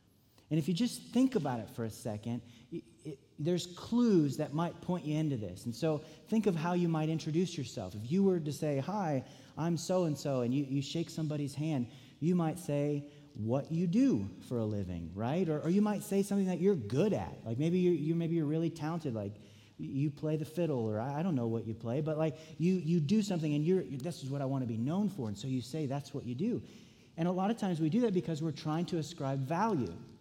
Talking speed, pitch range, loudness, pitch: 250 wpm, 130-175 Hz, -34 LUFS, 155 Hz